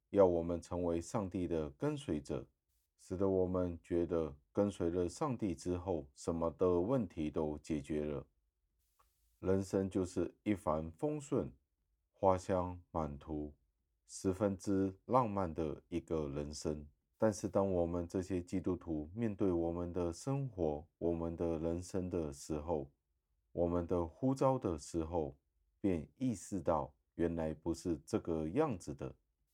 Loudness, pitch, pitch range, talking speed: -38 LUFS, 85 Hz, 75-95 Hz, 205 characters per minute